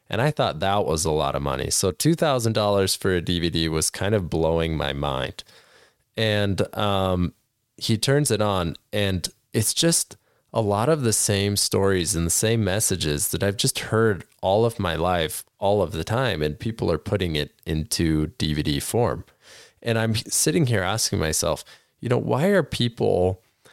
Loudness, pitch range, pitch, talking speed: -23 LUFS, 80-115 Hz, 100 Hz, 175 wpm